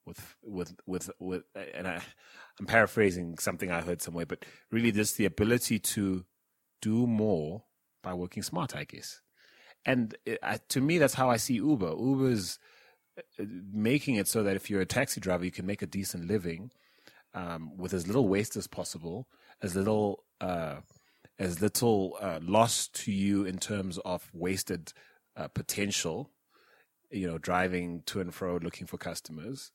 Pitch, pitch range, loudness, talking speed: 100 Hz, 90-110 Hz, -31 LUFS, 165 wpm